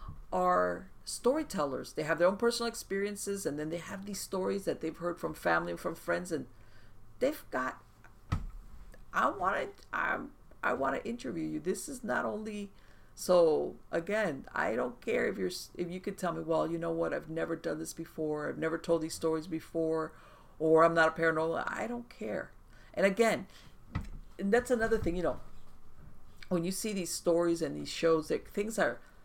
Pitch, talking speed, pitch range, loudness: 165 Hz, 190 wpm, 160-200 Hz, -33 LUFS